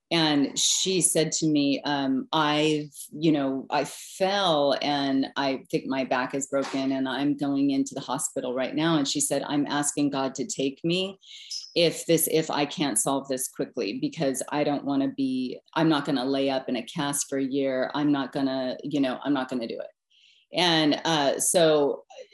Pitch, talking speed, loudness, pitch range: 140 Hz, 205 wpm, -25 LUFS, 135-155 Hz